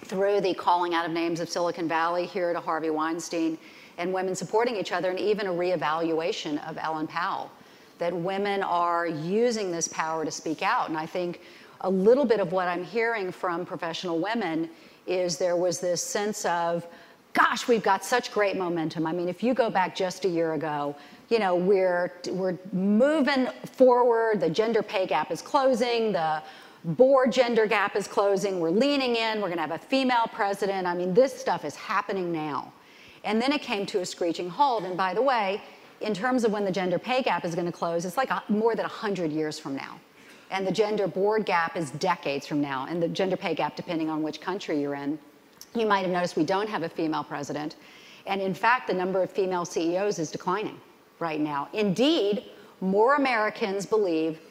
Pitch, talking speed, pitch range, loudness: 185 Hz, 200 wpm, 165-215 Hz, -26 LUFS